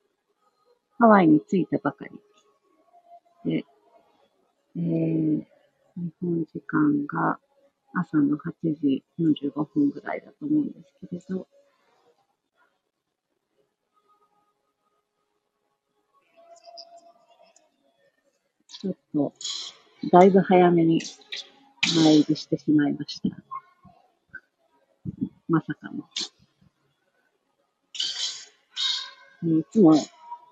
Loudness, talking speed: -24 LUFS, 125 characters per minute